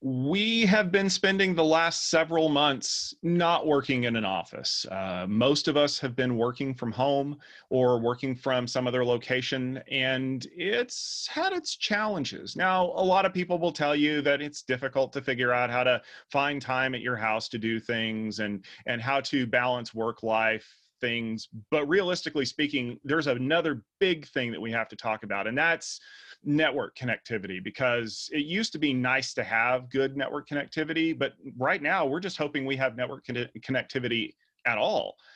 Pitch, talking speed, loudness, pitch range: 135 Hz, 180 wpm, -27 LUFS, 125-160 Hz